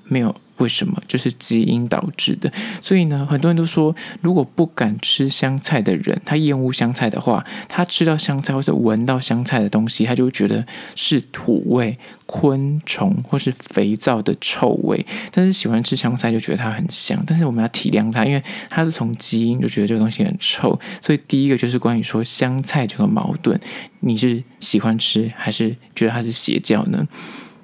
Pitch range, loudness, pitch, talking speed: 115-165 Hz, -19 LUFS, 130 Hz, 290 characters per minute